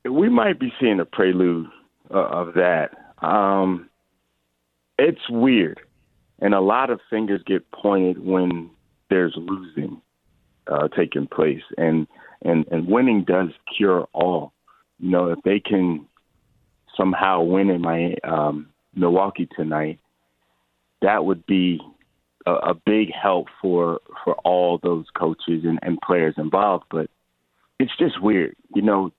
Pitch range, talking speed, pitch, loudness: 75-95 Hz, 135 wpm, 85 Hz, -21 LUFS